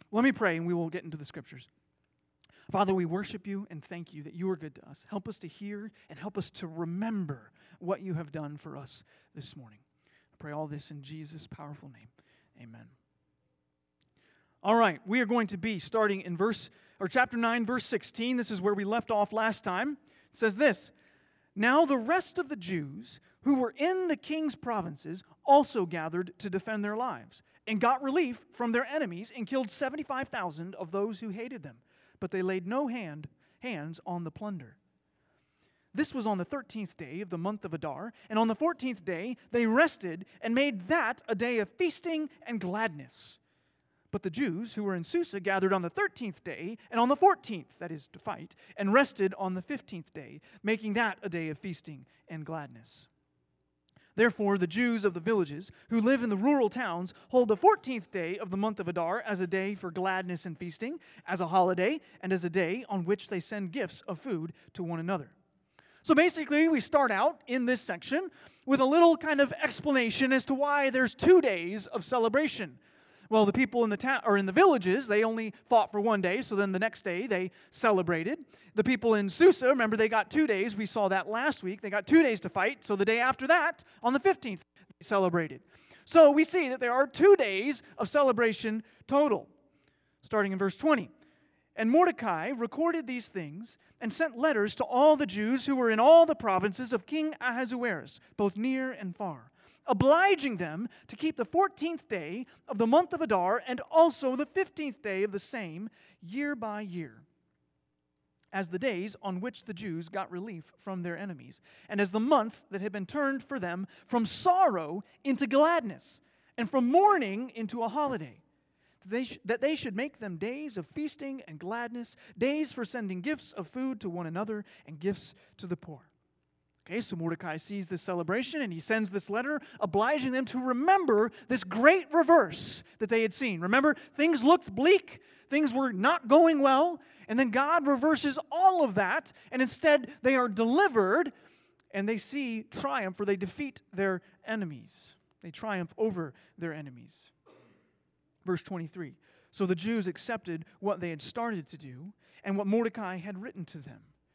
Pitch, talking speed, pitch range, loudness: 215 Hz, 195 wpm, 180-265 Hz, -29 LUFS